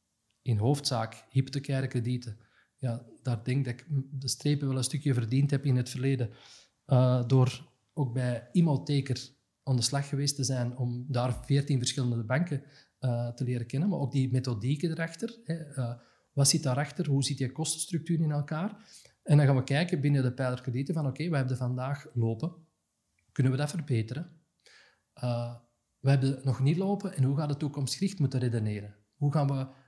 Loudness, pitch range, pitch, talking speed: -30 LUFS, 125-145 Hz, 135 Hz, 185 wpm